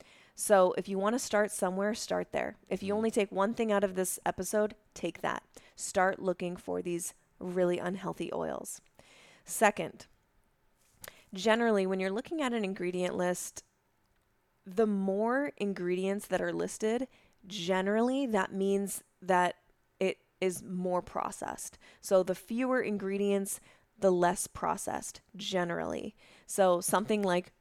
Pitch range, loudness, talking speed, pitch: 180-210 Hz, -32 LUFS, 135 wpm, 195 Hz